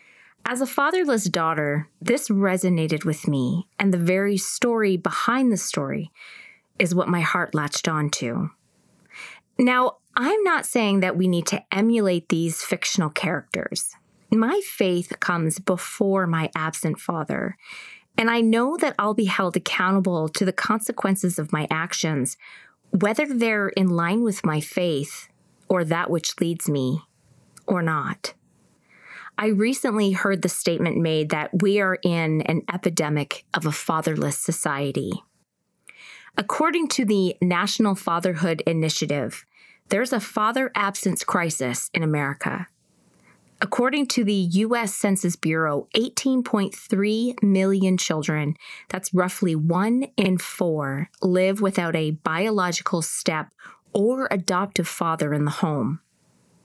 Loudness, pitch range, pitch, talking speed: -23 LUFS, 165-215 Hz, 185 Hz, 130 wpm